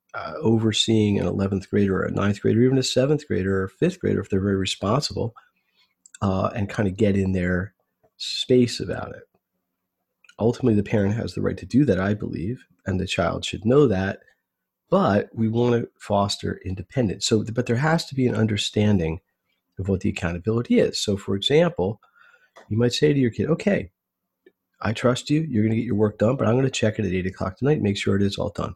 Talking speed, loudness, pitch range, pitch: 220 wpm, -23 LUFS, 95-120 Hz, 105 Hz